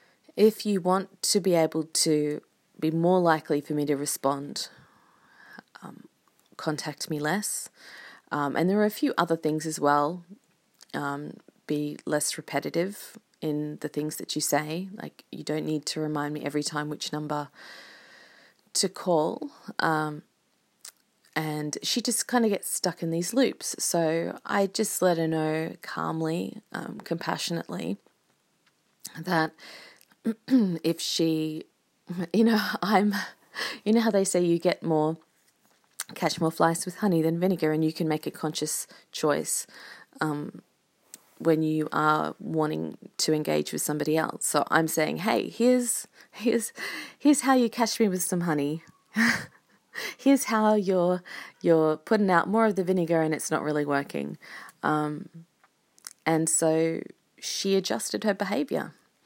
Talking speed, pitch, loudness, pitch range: 145 wpm, 165 Hz, -27 LUFS, 155-205 Hz